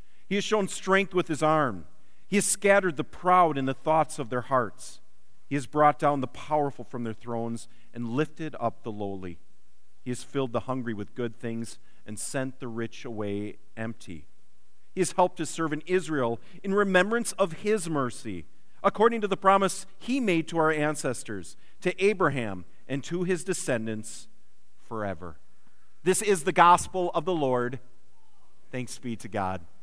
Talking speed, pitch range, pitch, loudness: 170 wpm, 115-180 Hz, 135 Hz, -27 LUFS